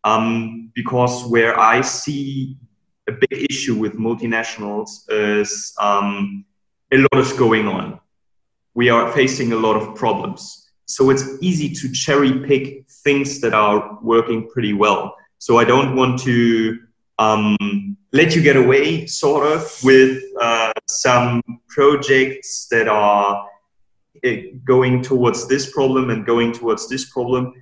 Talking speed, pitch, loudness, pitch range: 140 wpm, 125 Hz, -17 LUFS, 110-135 Hz